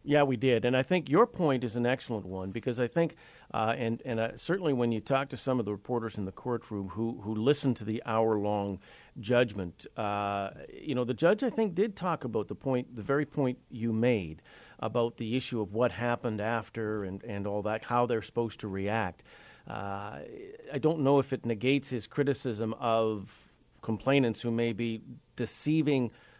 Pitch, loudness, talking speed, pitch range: 115 Hz, -31 LUFS, 195 wpm, 110-130 Hz